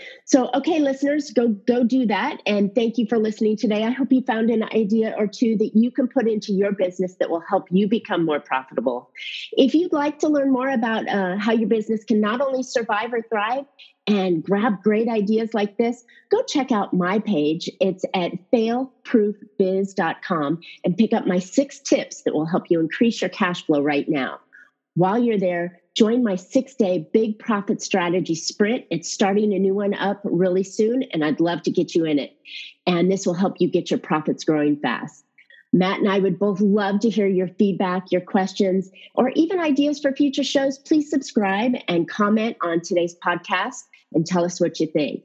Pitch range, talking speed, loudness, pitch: 185-245 Hz, 200 wpm, -21 LUFS, 210 Hz